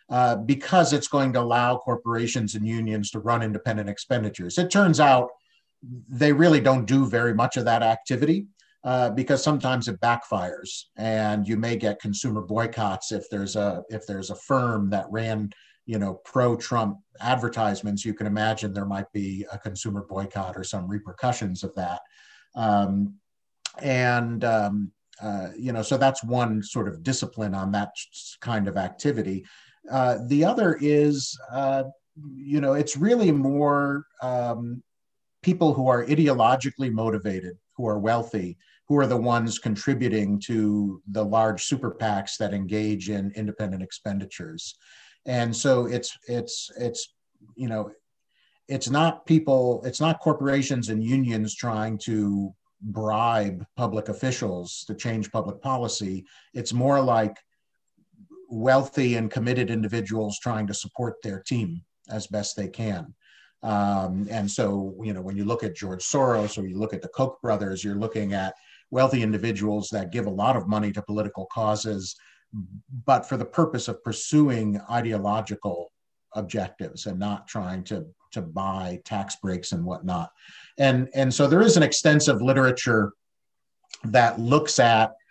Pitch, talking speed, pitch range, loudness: 115 Hz, 150 wpm, 105-130 Hz, -25 LUFS